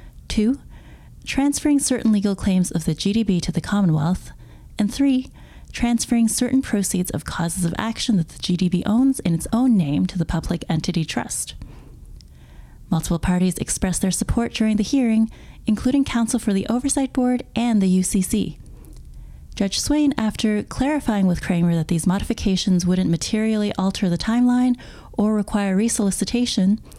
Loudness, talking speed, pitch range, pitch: -21 LUFS, 150 wpm, 180-235 Hz, 205 Hz